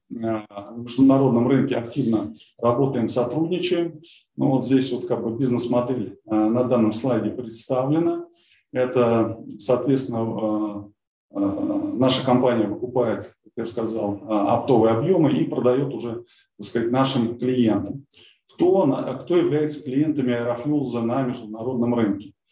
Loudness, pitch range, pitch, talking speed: -22 LUFS, 115-135 Hz, 125 Hz, 110 wpm